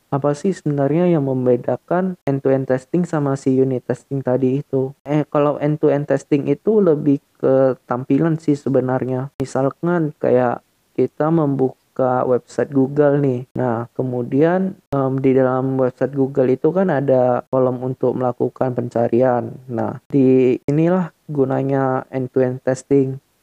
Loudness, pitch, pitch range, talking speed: -18 LUFS, 135 Hz, 130-145 Hz, 130 wpm